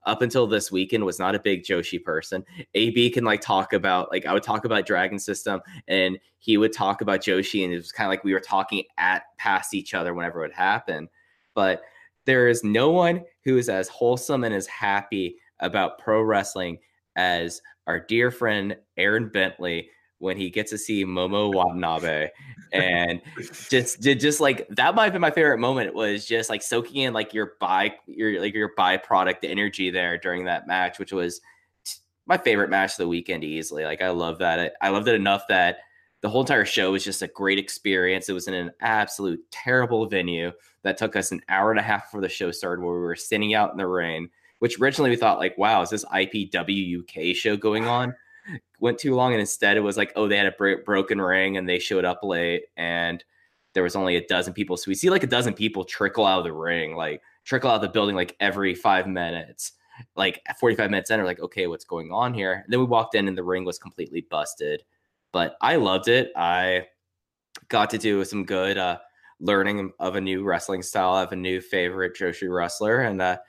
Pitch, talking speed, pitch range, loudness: 95 Hz, 215 wpm, 90-110 Hz, -24 LUFS